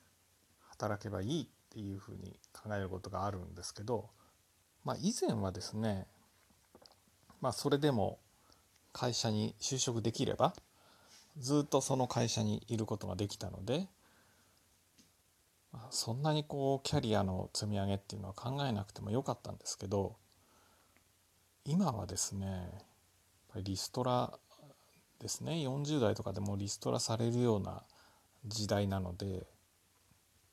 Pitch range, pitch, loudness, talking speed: 95-120 Hz, 105 Hz, -37 LUFS, 270 characters per minute